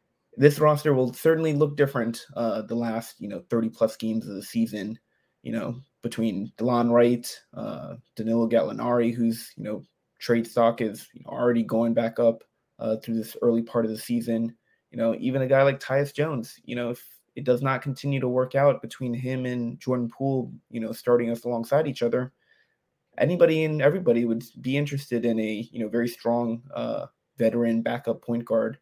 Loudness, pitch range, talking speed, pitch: -25 LUFS, 115-130 Hz, 190 wpm, 120 Hz